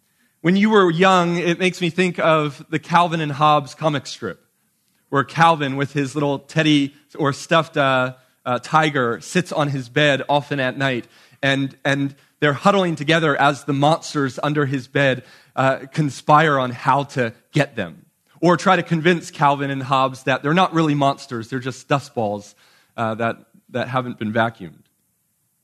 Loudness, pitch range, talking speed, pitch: -19 LUFS, 130-160 Hz, 170 wpm, 145 Hz